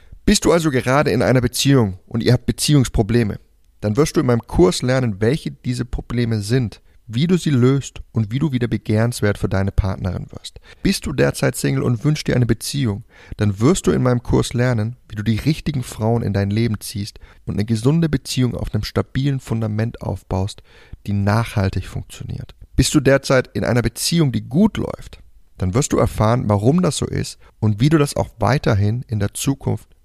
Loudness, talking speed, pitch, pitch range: -19 LUFS, 195 wpm, 120 Hz, 105-135 Hz